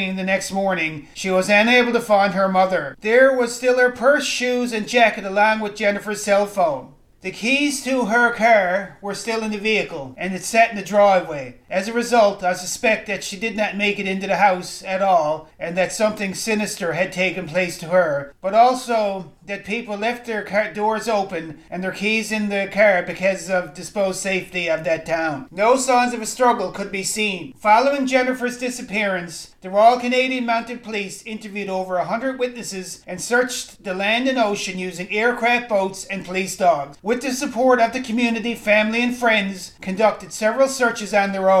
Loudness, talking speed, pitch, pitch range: -20 LUFS, 195 wpm, 205 Hz, 185-235 Hz